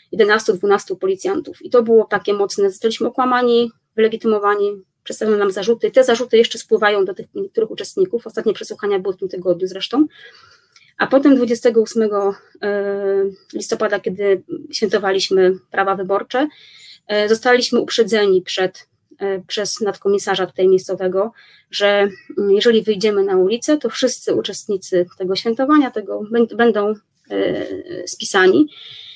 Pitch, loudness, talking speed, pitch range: 220 Hz, -17 LUFS, 115 wpm, 195-260 Hz